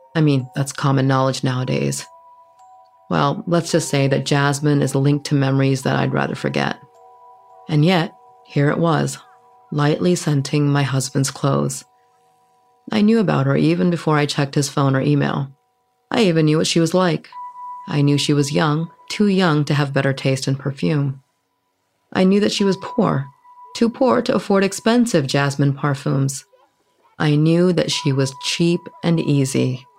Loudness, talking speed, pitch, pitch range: -18 LUFS, 165 wpm, 155 Hz, 140-225 Hz